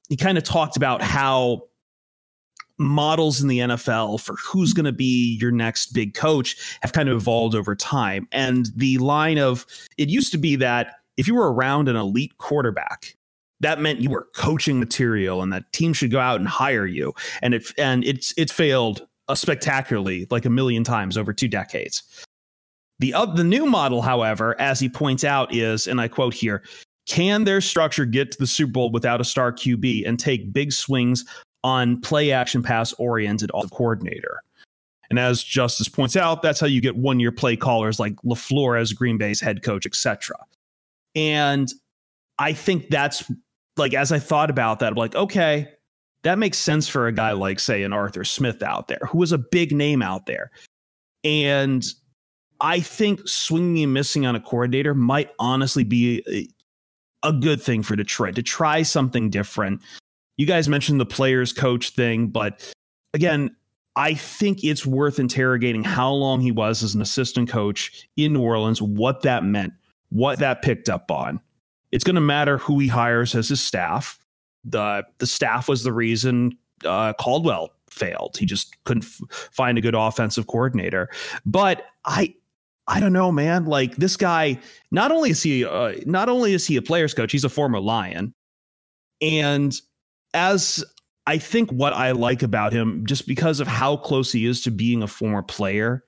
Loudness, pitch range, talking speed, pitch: -21 LUFS, 115-150 Hz, 180 wpm, 130 Hz